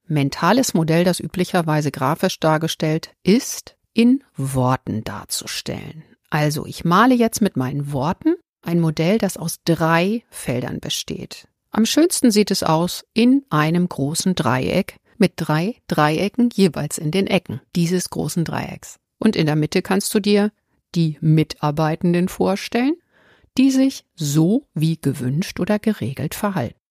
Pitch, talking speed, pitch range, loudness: 175 Hz, 135 wpm, 155-210 Hz, -20 LUFS